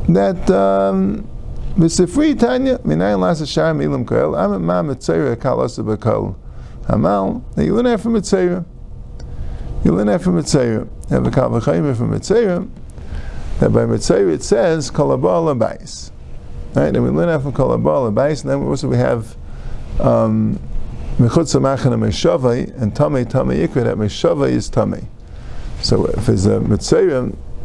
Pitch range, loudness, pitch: 105-170 Hz, -16 LUFS, 125 Hz